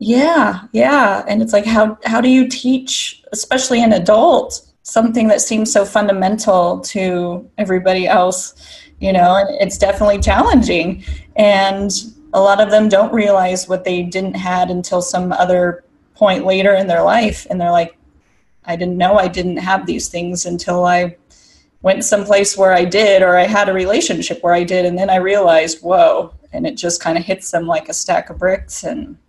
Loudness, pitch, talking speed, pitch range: -14 LUFS, 190 Hz, 180 wpm, 180-210 Hz